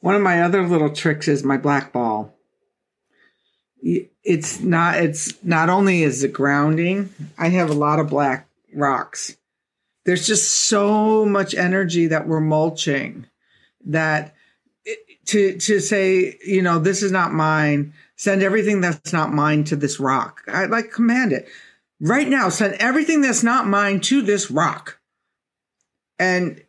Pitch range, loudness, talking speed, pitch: 155-200 Hz, -19 LUFS, 150 wpm, 180 Hz